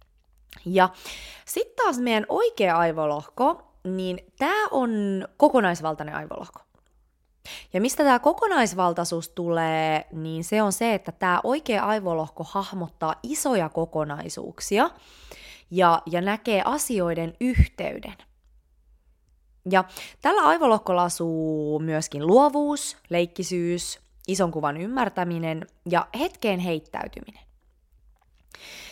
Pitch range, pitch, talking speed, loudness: 160-220 Hz, 180 Hz, 95 wpm, -24 LUFS